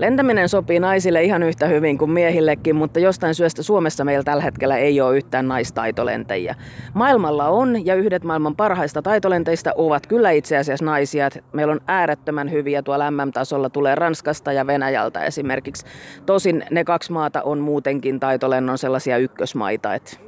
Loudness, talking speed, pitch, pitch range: -19 LUFS, 150 wpm, 150 Hz, 140-170 Hz